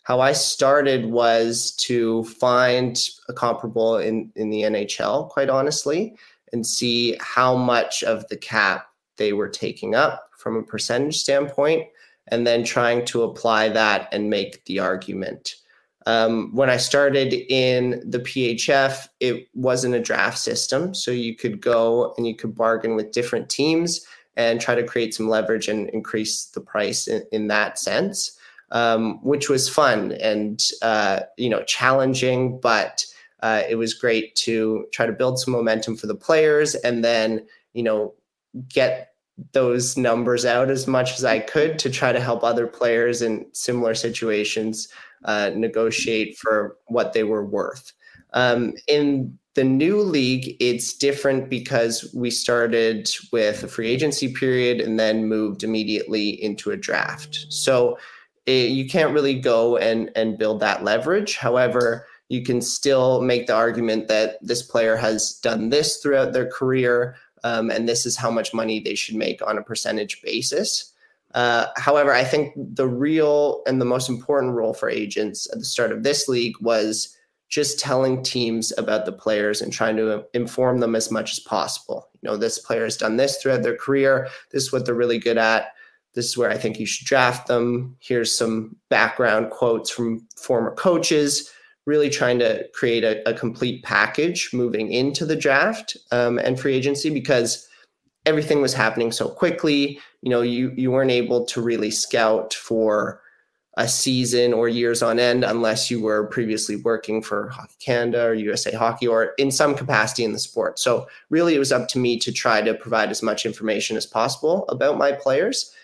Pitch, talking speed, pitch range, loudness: 120 Hz, 175 wpm, 110-130 Hz, -21 LUFS